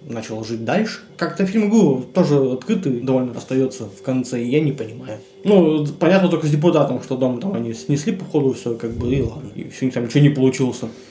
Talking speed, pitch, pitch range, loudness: 200 wpm, 135 Hz, 120-165 Hz, -19 LUFS